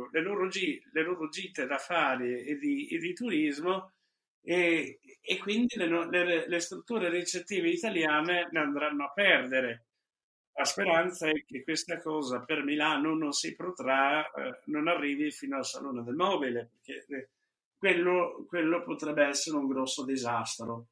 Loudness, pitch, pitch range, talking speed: -30 LUFS, 160 Hz, 145-180 Hz, 145 wpm